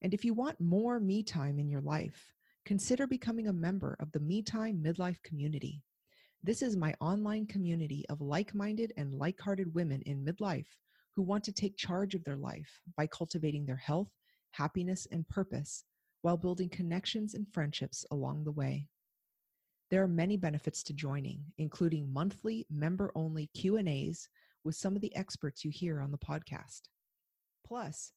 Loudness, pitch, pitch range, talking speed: -37 LUFS, 170 Hz, 150-200 Hz, 160 wpm